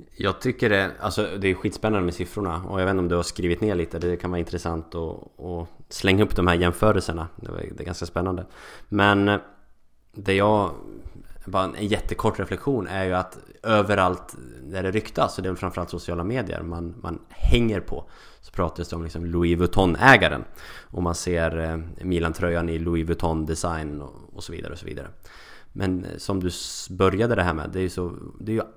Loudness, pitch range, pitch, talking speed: -24 LUFS, 85-100 Hz, 90 Hz, 195 wpm